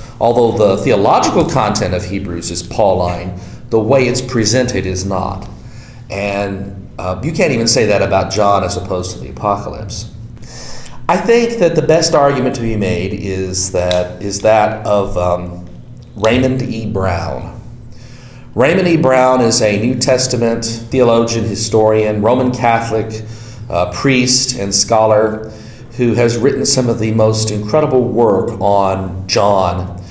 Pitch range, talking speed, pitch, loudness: 95-125 Hz, 145 wpm, 110 Hz, -14 LUFS